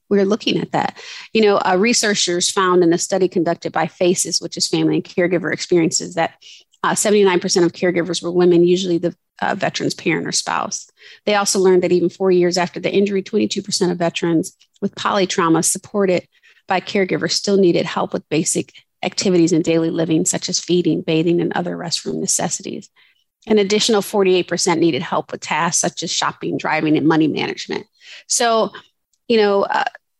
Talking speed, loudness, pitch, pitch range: 175 wpm, -17 LUFS, 180 Hz, 170-200 Hz